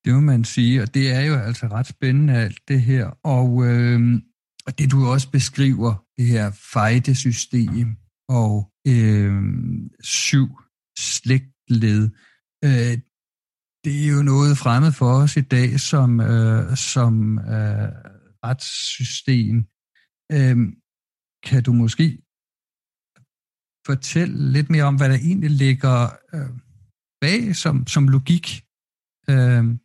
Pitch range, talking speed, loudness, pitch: 115-140 Hz, 125 wpm, -19 LUFS, 125 Hz